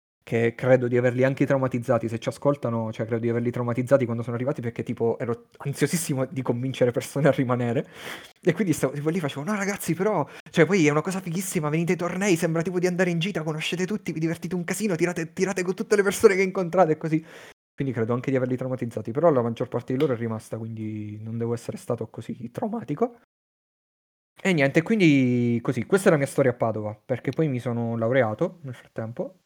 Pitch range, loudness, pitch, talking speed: 120-175 Hz, -25 LUFS, 140 Hz, 215 wpm